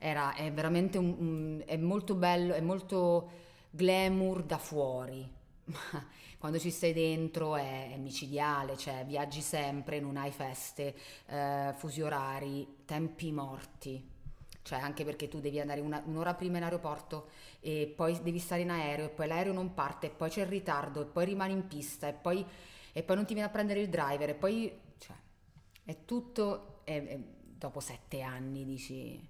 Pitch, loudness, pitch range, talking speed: 155 Hz, -36 LUFS, 140-175 Hz, 175 wpm